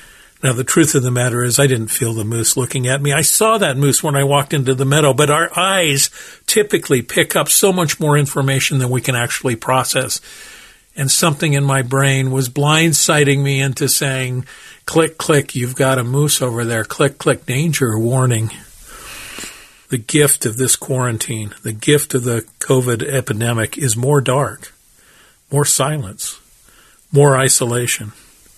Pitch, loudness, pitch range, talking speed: 135 Hz, -15 LUFS, 125-145 Hz, 170 wpm